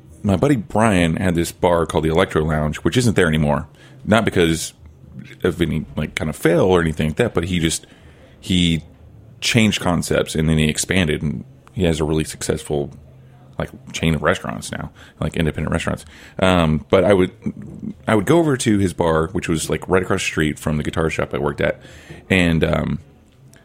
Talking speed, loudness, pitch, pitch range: 195 wpm, -19 LUFS, 80 Hz, 75-95 Hz